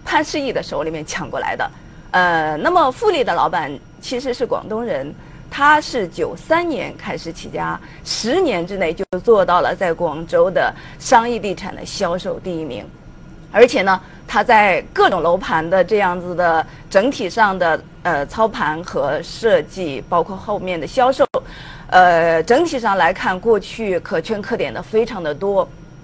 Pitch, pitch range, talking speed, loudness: 190 Hz, 170-245 Hz, 240 characters per minute, -18 LUFS